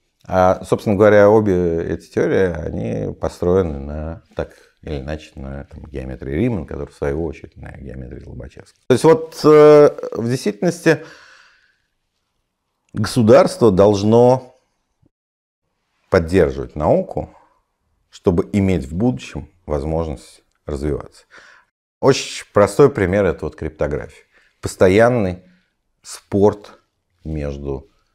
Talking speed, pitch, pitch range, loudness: 100 wpm, 95 Hz, 75-120 Hz, -16 LUFS